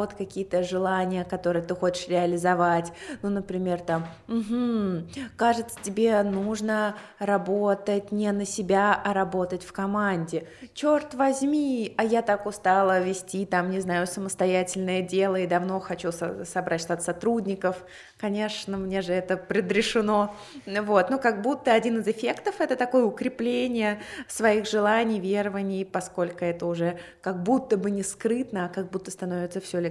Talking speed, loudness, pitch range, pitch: 145 wpm, -26 LUFS, 180-215 Hz, 195 Hz